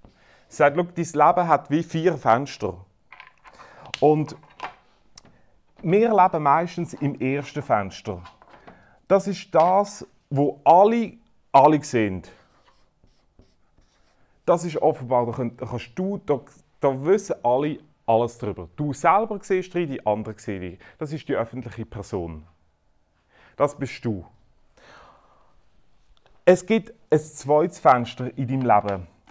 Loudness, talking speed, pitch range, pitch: -22 LUFS, 120 wpm, 110-170 Hz, 140 Hz